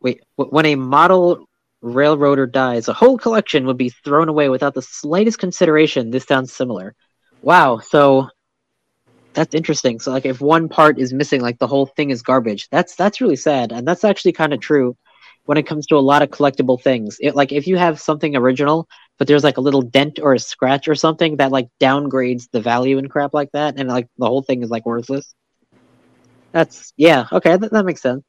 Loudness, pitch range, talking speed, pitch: -16 LUFS, 130-155 Hz, 210 wpm, 140 Hz